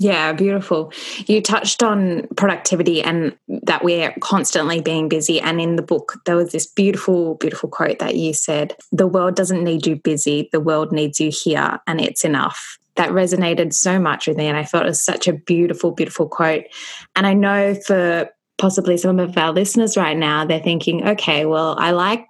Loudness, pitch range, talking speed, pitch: -18 LUFS, 160-190 Hz, 195 wpm, 170 Hz